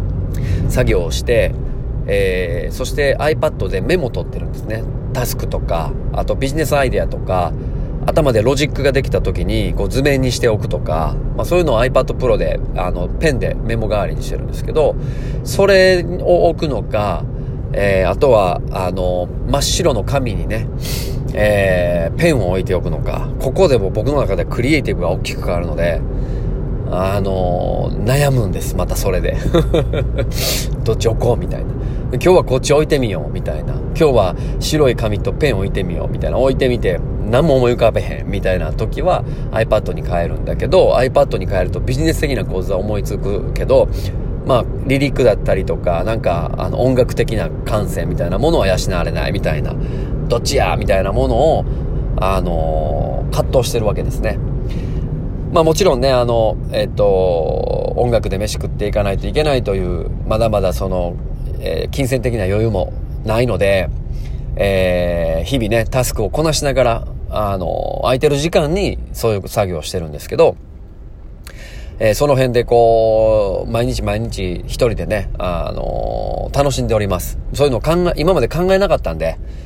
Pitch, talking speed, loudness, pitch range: 120 Hz, 355 characters per minute, -17 LUFS, 95-135 Hz